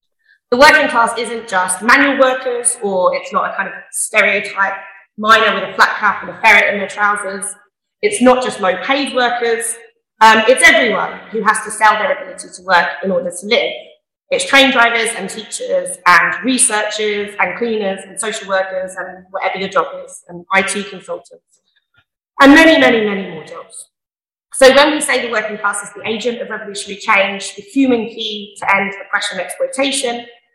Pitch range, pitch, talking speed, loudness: 195-260 Hz, 220 Hz, 185 wpm, -13 LUFS